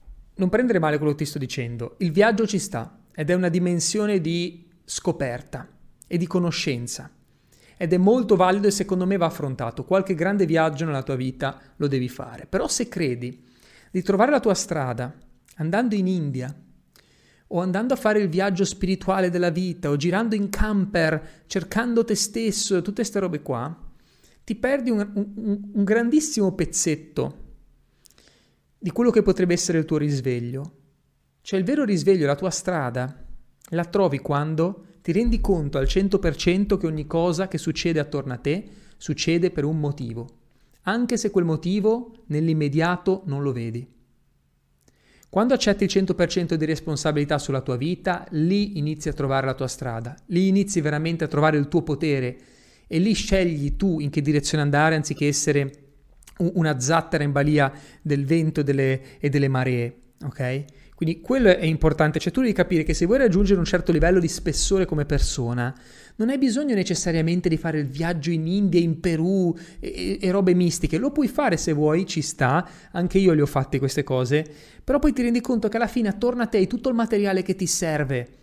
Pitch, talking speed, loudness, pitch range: 170 Hz, 180 wpm, -23 LUFS, 145-195 Hz